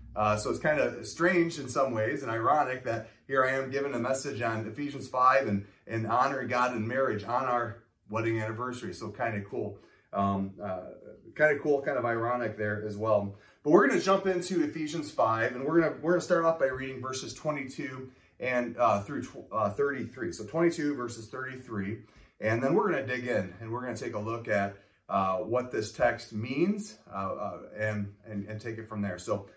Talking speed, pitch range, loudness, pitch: 215 wpm, 110-140 Hz, -30 LUFS, 120 Hz